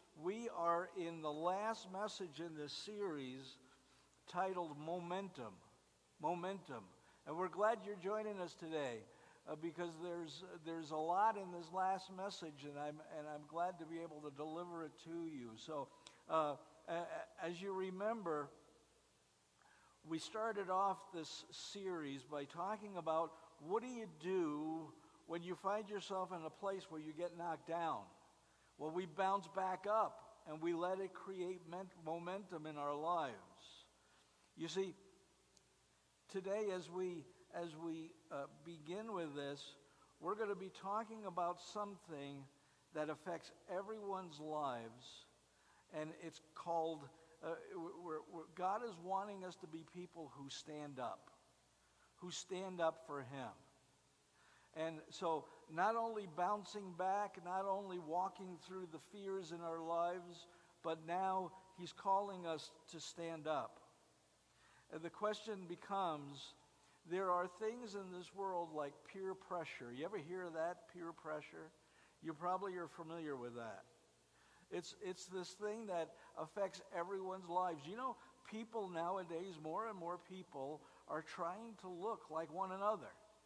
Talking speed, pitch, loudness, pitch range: 145 wpm, 170 Hz, -46 LUFS, 155-190 Hz